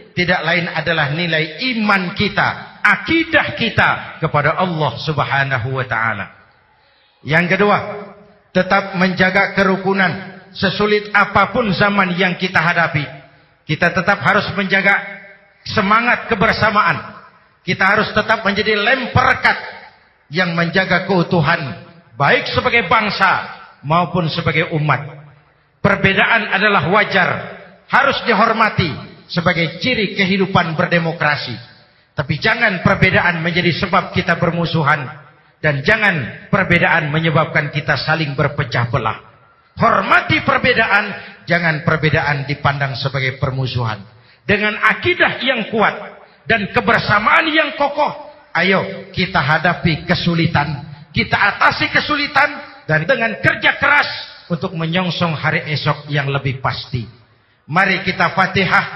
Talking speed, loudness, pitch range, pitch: 105 wpm, -15 LUFS, 155-200 Hz, 175 Hz